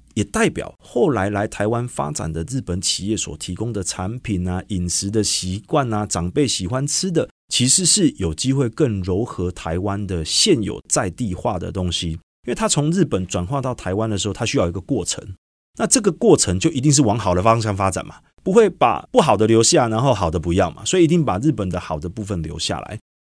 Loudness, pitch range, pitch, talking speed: -19 LUFS, 90-125 Hz, 100 Hz, 315 characters per minute